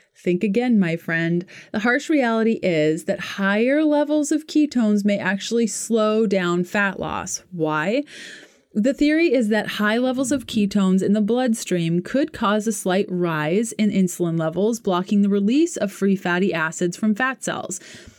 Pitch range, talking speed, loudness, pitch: 185-240 Hz, 160 wpm, -21 LUFS, 210 Hz